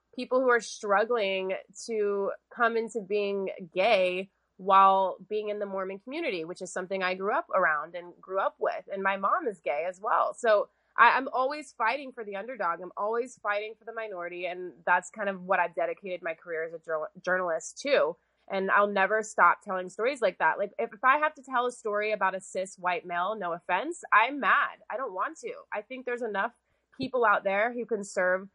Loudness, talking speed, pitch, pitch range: -28 LUFS, 210 wpm, 200 Hz, 185-235 Hz